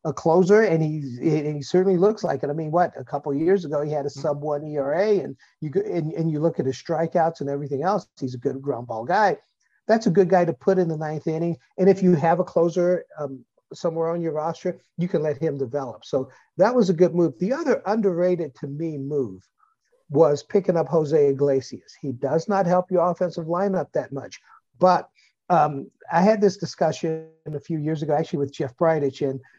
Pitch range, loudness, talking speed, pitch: 145-180 Hz, -23 LUFS, 220 wpm, 165 Hz